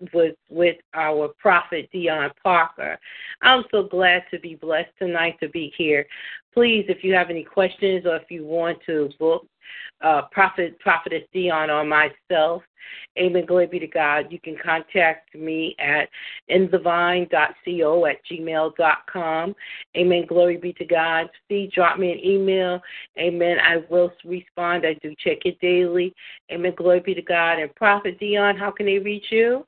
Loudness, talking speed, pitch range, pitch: -21 LUFS, 160 wpm, 160-185 Hz, 175 Hz